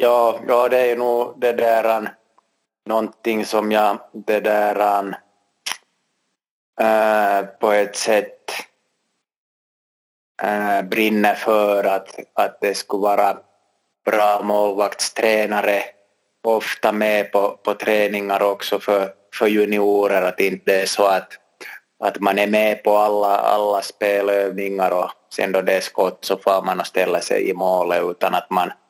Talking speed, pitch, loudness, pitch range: 135 wpm, 105 Hz, -19 LUFS, 100-110 Hz